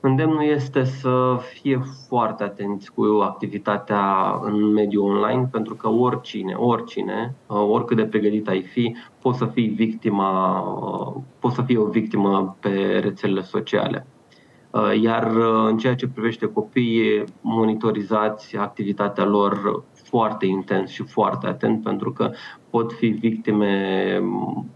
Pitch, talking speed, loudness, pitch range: 110 Hz, 120 wpm, -22 LUFS, 105-125 Hz